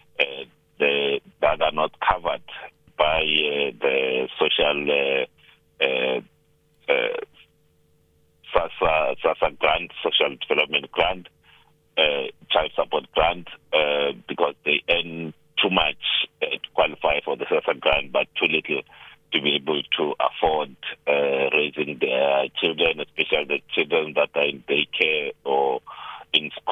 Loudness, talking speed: -22 LUFS, 125 wpm